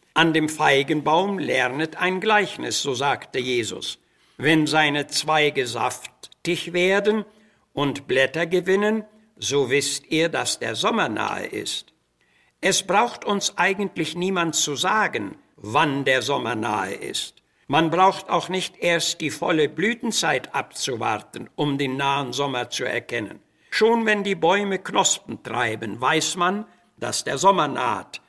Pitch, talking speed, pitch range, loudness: 160 Hz, 135 wpm, 140-190 Hz, -22 LUFS